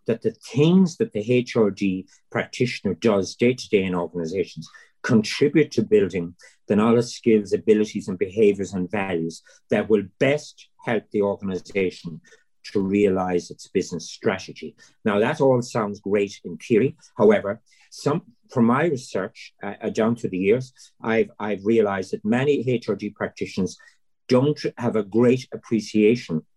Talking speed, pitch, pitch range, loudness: 145 wpm, 110 Hz, 100-125 Hz, -23 LUFS